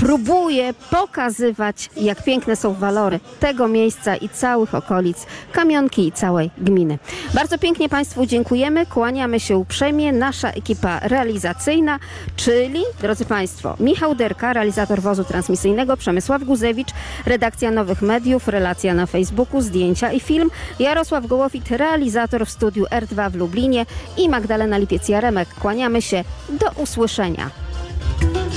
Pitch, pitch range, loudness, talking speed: 235 Hz, 200-270 Hz, -19 LUFS, 125 wpm